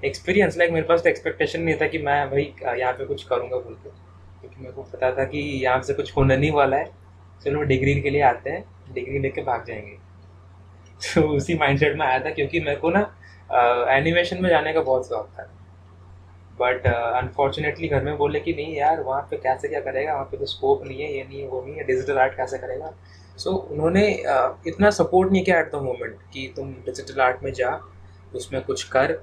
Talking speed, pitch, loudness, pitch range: 220 wpm, 140 Hz, -22 LUFS, 110-170 Hz